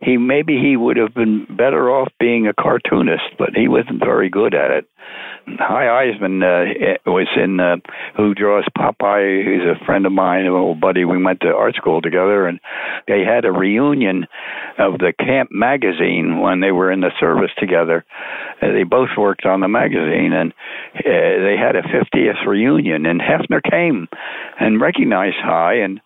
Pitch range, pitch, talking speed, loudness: 90-105 Hz, 95 Hz, 180 wpm, -16 LUFS